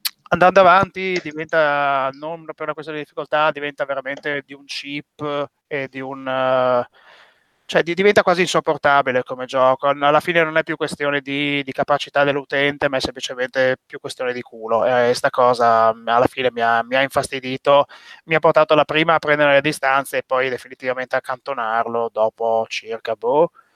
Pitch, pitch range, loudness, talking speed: 140 Hz, 130-155 Hz, -18 LUFS, 175 wpm